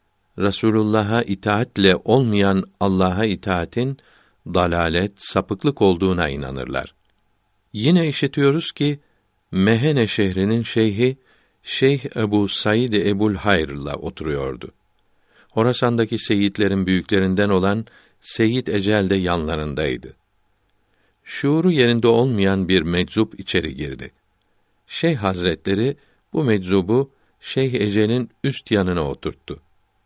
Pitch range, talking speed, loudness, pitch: 95-115 Hz, 90 wpm, -20 LUFS, 105 Hz